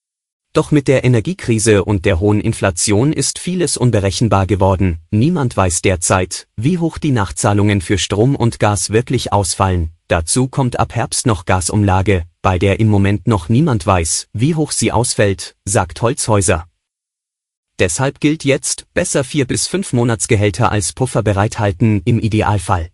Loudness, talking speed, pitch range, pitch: -15 LUFS, 150 wpm, 100-130 Hz, 110 Hz